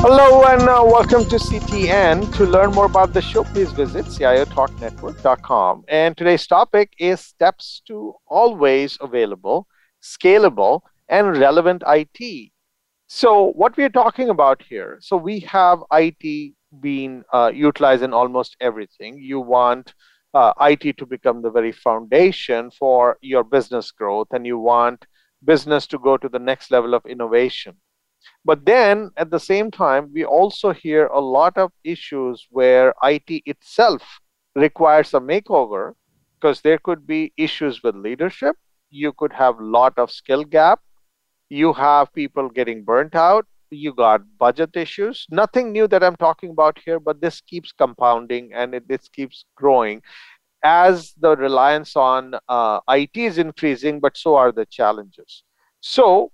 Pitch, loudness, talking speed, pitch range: 150 Hz, -17 LUFS, 150 wpm, 130-185 Hz